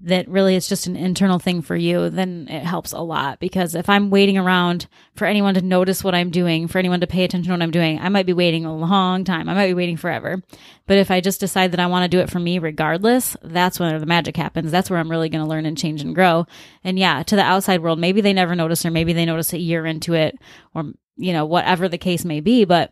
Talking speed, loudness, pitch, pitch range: 270 wpm, -19 LUFS, 180 Hz, 165-185 Hz